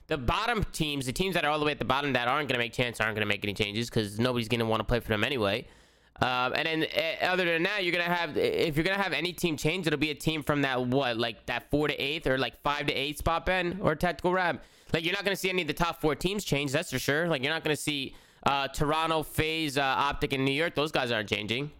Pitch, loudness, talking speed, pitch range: 150 Hz, -28 LUFS, 285 wpm, 125-170 Hz